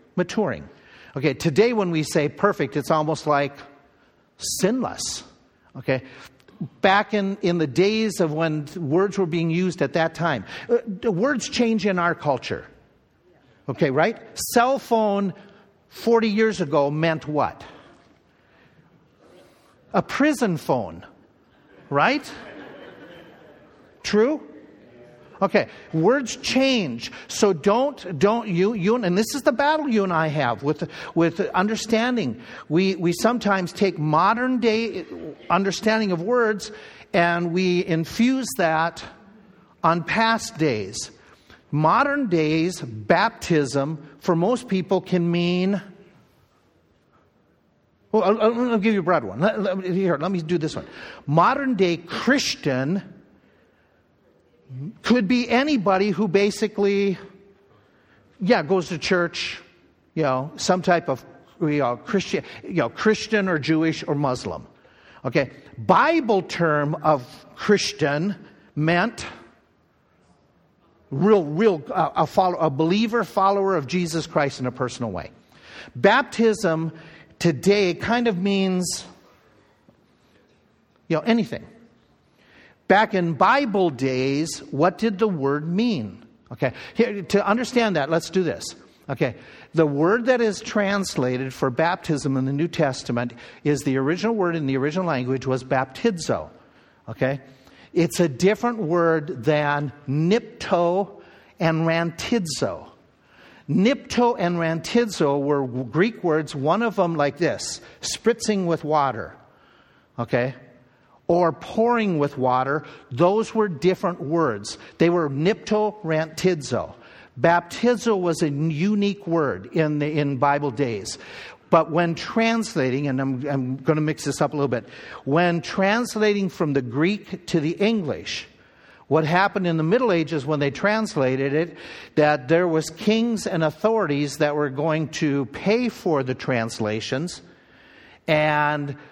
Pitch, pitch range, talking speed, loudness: 170 Hz, 150-205 Hz, 125 wpm, -22 LUFS